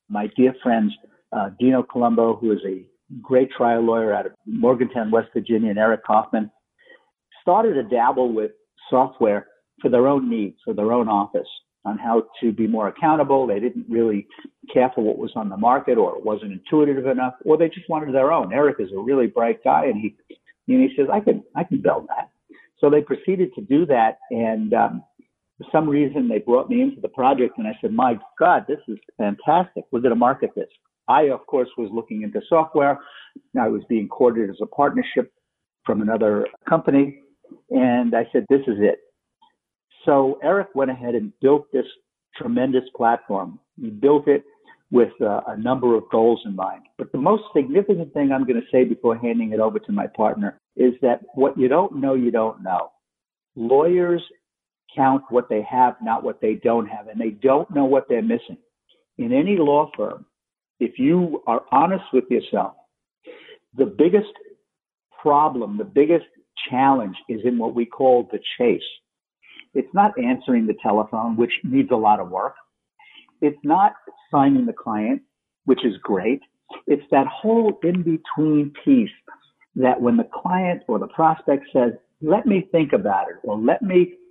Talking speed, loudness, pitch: 180 wpm, -20 LUFS, 140 Hz